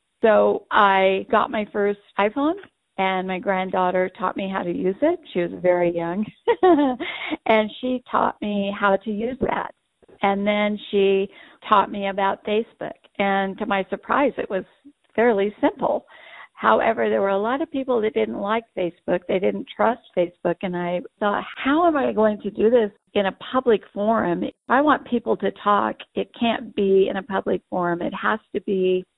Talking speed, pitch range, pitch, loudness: 180 wpm, 190-235 Hz, 205 Hz, -22 LUFS